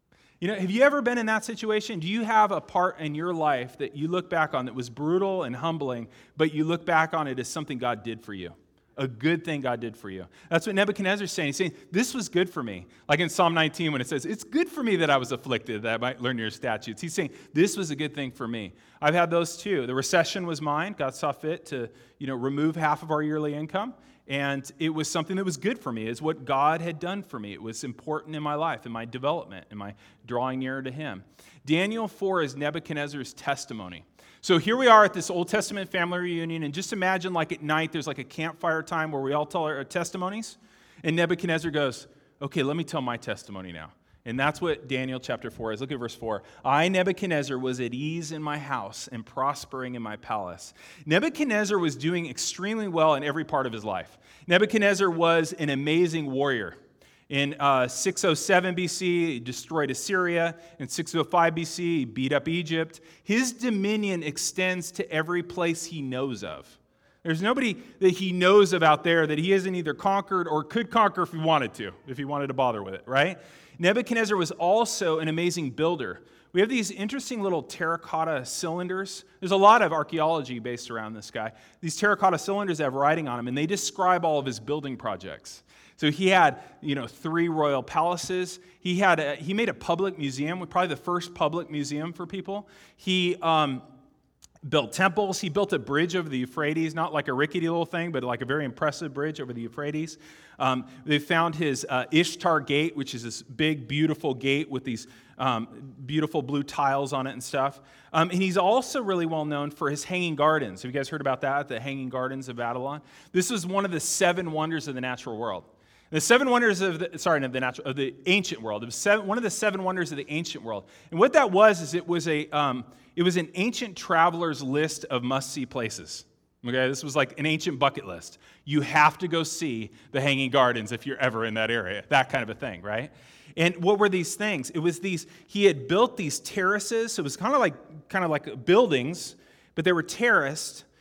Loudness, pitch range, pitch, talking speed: -26 LUFS, 135-180 Hz, 155 Hz, 220 wpm